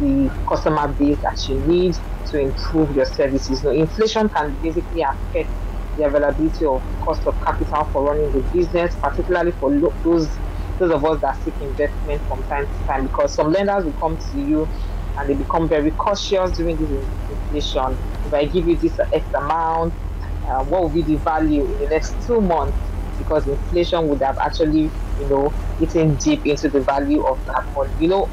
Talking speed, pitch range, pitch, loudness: 190 wpm, 130-170 Hz, 150 Hz, -20 LUFS